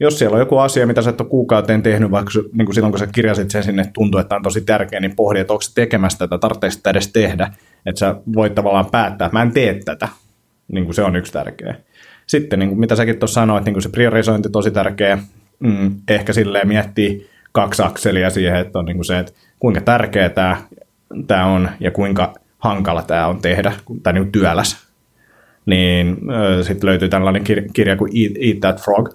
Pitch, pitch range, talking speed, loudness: 100 Hz, 95-110 Hz, 200 wpm, -16 LUFS